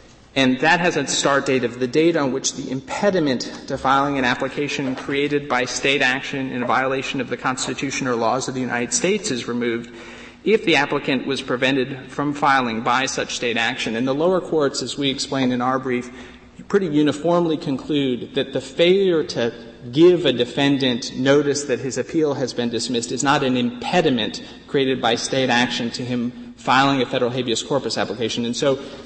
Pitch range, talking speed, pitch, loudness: 125-140 Hz, 190 wpm, 135 Hz, -20 LUFS